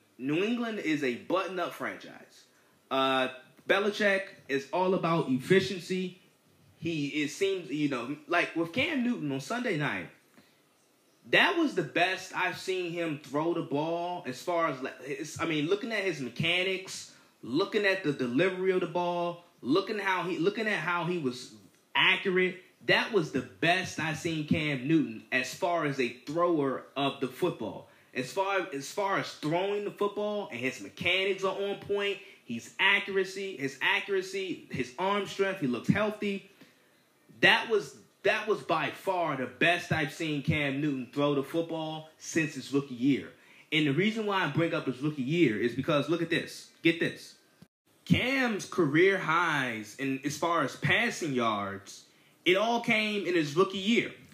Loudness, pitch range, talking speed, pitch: -29 LUFS, 145-195 Hz, 170 wpm, 170 Hz